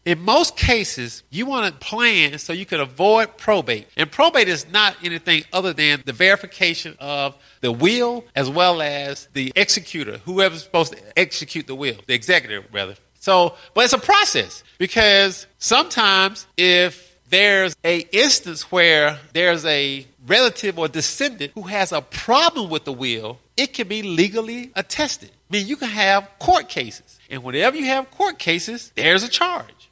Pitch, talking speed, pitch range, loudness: 180 Hz, 165 wpm, 150-220 Hz, -18 LUFS